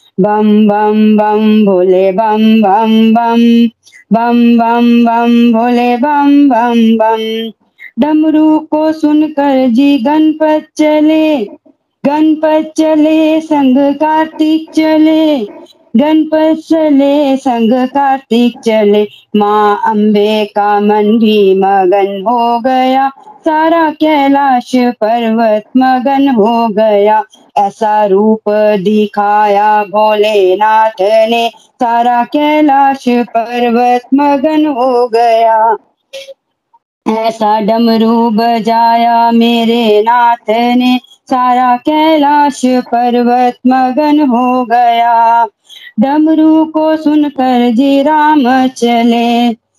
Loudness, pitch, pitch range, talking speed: -9 LUFS, 240 Hz, 225-295 Hz, 90 wpm